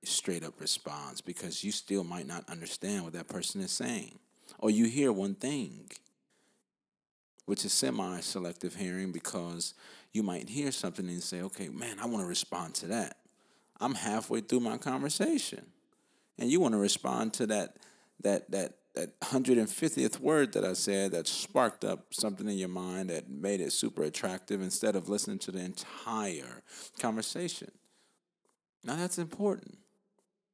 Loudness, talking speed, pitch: -33 LUFS, 155 wpm, 105 Hz